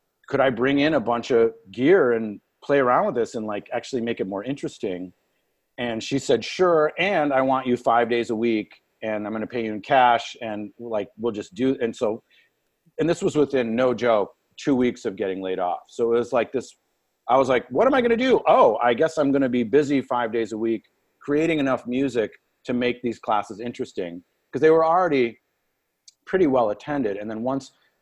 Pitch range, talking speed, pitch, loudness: 115-140 Hz, 220 wpm, 120 Hz, -23 LUFS